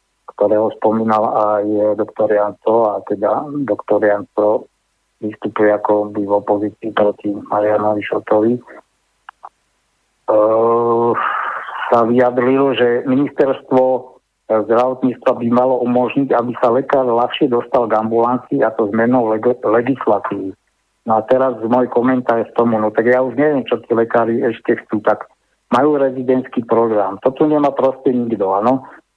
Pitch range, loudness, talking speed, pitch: 105-125 Hz, -16 LUFS, 135 wpm, 115 Hz